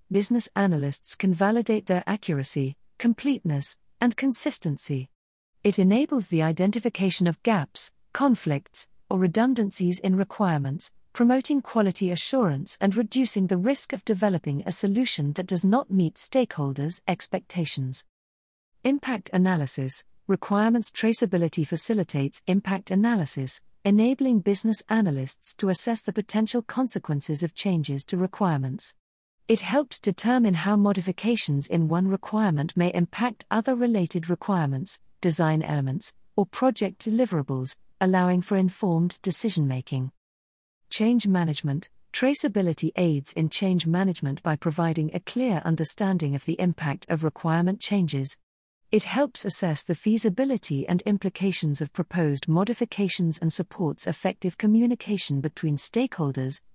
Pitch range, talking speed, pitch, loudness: 155-215 Hz, 120 wpm, 185 Hz, -25 LUFS